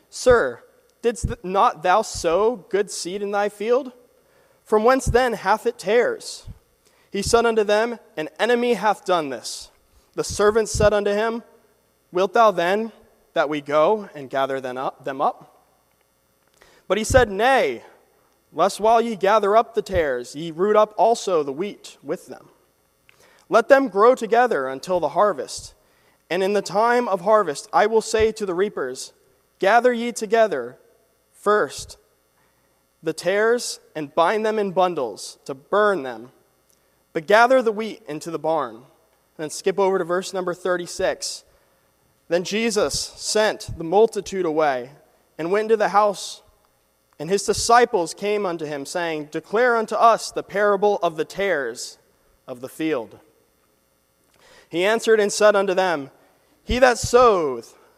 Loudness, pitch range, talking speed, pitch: -21 LUFS, 160-230 Hz, 150 wpm, 205 Hz